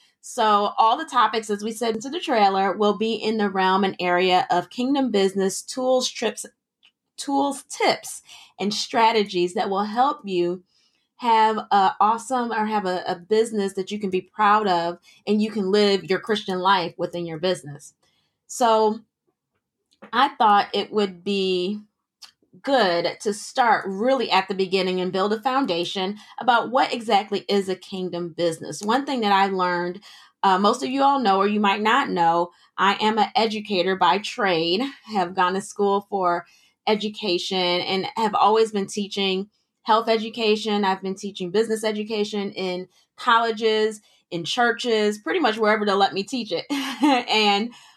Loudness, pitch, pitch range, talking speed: -22 LUFS, 205 Hz, 185-225 Hz, 165 wpm